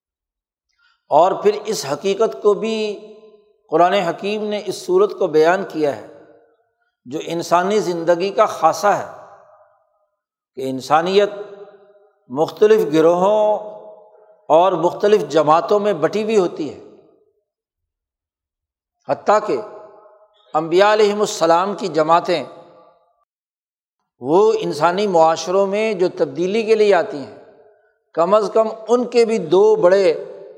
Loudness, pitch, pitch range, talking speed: -17 LUFS, 210 Hz, 170-215 Hz, 115 wpm